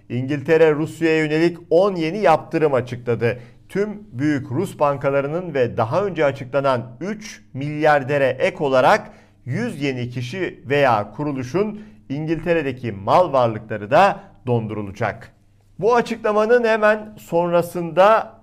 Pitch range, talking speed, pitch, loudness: 120-175 Hz, 105 wpm, 145 Hz, -20 LUFS